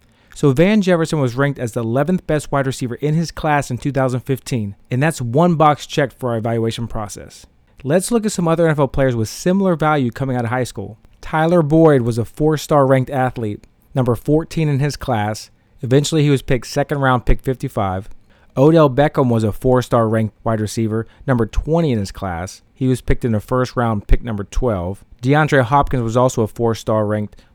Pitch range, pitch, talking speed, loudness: 115-145 Hz, 130 Hz, 205 wpm, -17 LUFS